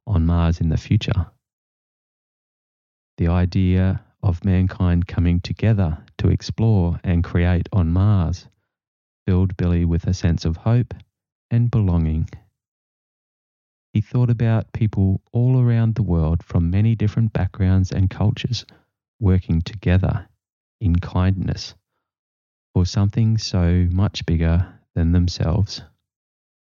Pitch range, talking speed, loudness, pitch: 85-110 Hz, 115 wpm, -20 LUFS, 95 Hz